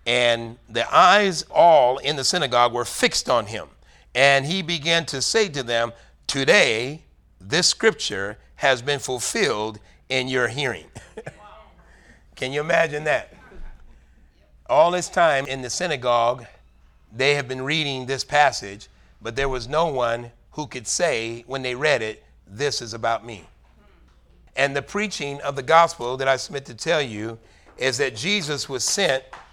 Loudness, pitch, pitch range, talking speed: -21 LUFS, 125 Hz, 110-145 Hz, 155 wpm